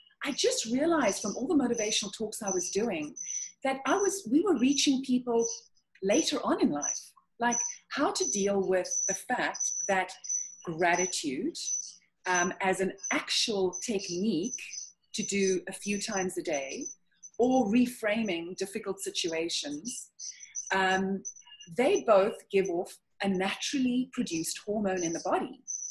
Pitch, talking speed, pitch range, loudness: 215 Hz, 135 wpm, 190-270 Hz, -30 LUFS